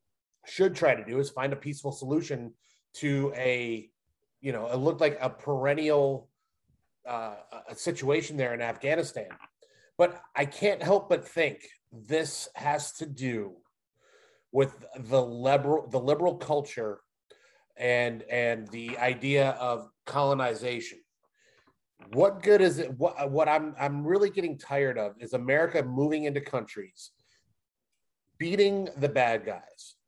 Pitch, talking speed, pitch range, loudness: 140 Hz, 135 wpm, 125-155 Hz, -28 LUFS